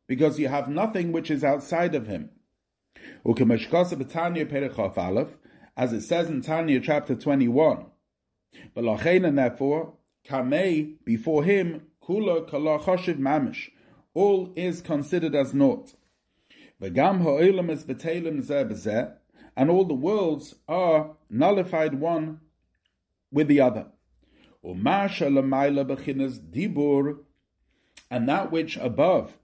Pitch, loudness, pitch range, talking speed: 155 Hz, -25 LUFS, 140-170 Hz, 75 wpm